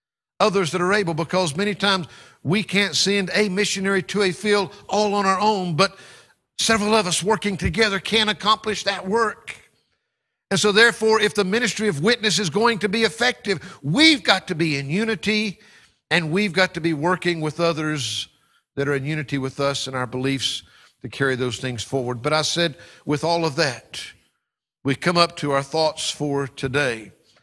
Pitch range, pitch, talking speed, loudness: 150-210 Hz, 185 Hz, 185 wpm, -21 LUFS